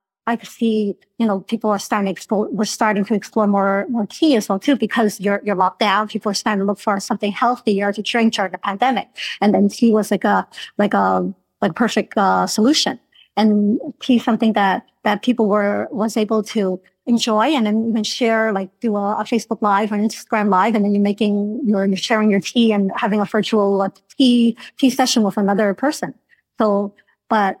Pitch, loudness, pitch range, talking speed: 215 Hz, -18 LUFS, 200-225 Hz, 210 wpm